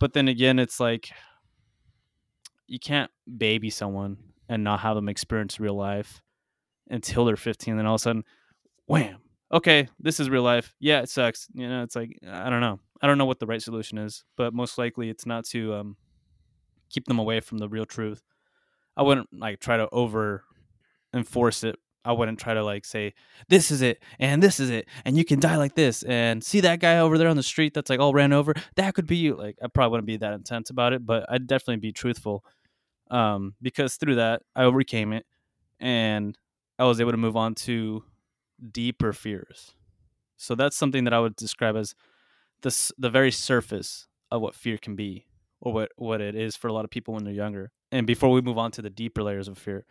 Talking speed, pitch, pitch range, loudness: 215 wpm, 115 Hz, 110-130 Hz, -25 LUFS